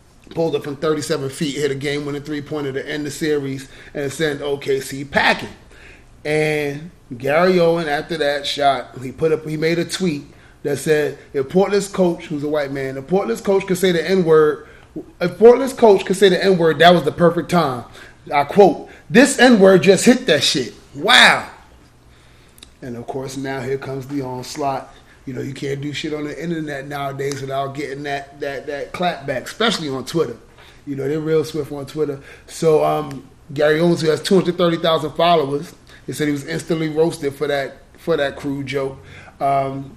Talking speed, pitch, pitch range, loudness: 190 wpm, 150 Hz, 140-170 Hz, -18 LUFS